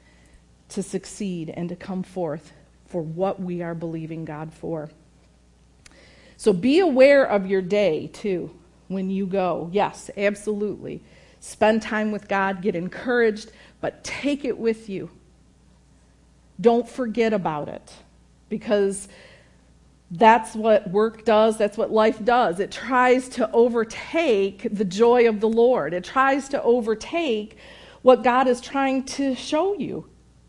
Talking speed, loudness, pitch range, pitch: 135 wpm, -22 LUFS, 175-235 Hz, 210 Hz